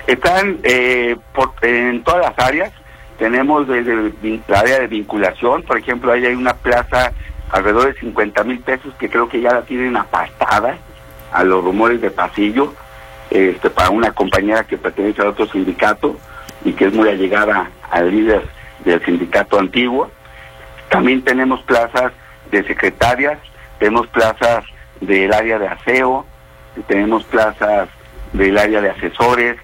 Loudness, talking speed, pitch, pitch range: -15 LUFS, 150 wpm, 110 Hz, 90-125 Hz